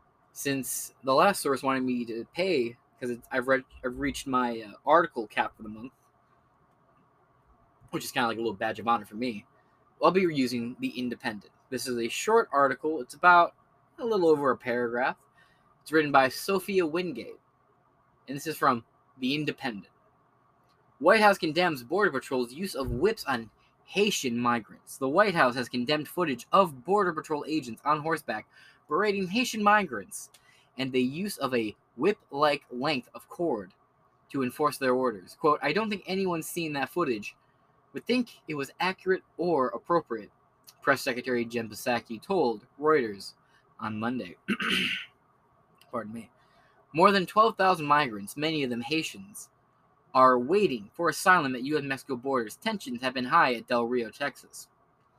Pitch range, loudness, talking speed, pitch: 125-170 Hz, -28 LUFS, 160 wpm, 140 Hz